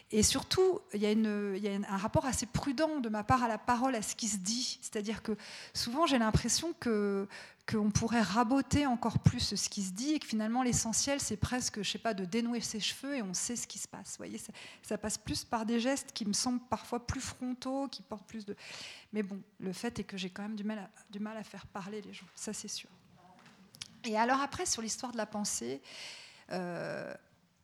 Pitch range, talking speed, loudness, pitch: 205-245 Hz, 235 wpm, -34 LUFS, 220 Hz